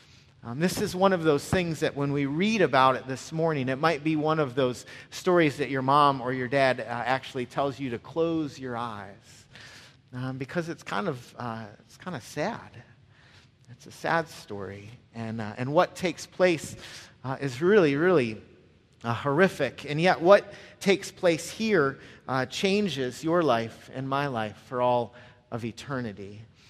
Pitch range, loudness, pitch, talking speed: 120-160 Hz, -27 LUFS, 135 Hz, 180 wpm